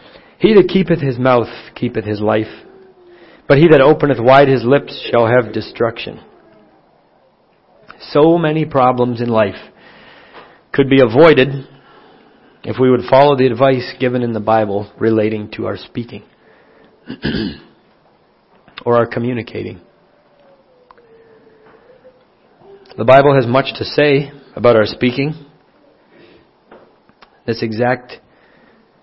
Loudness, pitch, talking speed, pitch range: -14 LUFS, 130 Hz, 110 wpm, 115-145 Hz